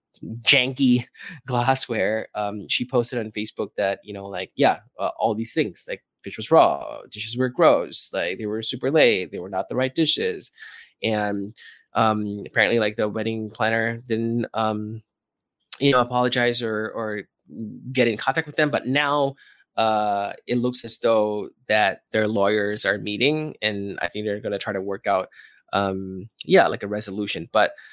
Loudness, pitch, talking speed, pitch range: -23 LUFS, 110 Hz, 175 wpm, 105-125 Hz